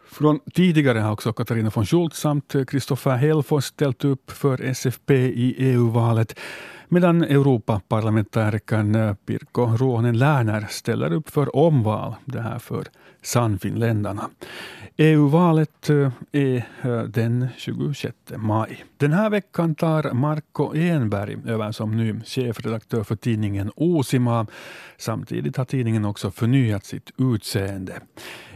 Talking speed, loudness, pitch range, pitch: 115 wpm, -22 LUFS, 110-145 Hz, 125 Hz